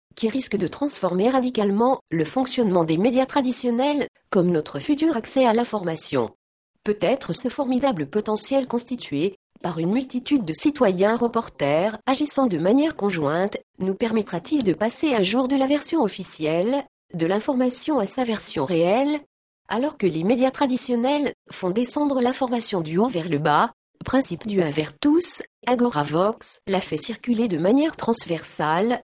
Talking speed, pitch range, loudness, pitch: 150 wpm, 185-265 Hz, -22 LUFS, 230 Hz